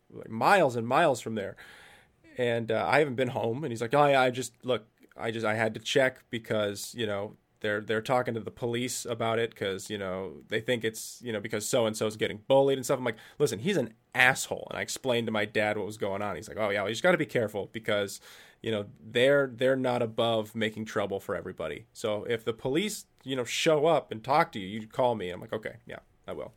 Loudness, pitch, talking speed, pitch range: -29 LUFS, 115 Hz, 255 wpm, 110-125 Hz